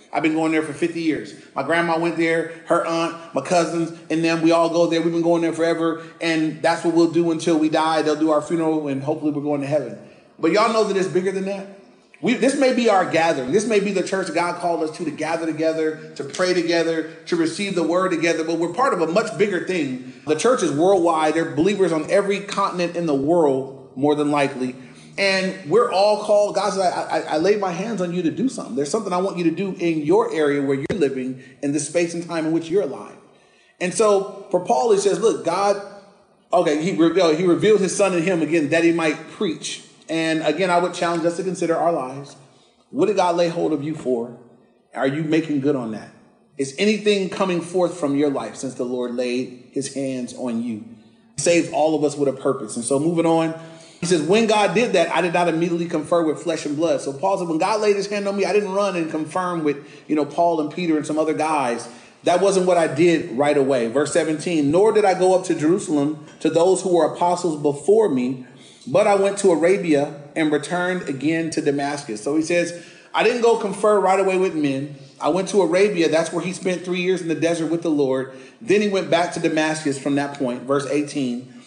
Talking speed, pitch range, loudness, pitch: 240 wpm, 150-185 Hz, -20 LUFS, 165 Hz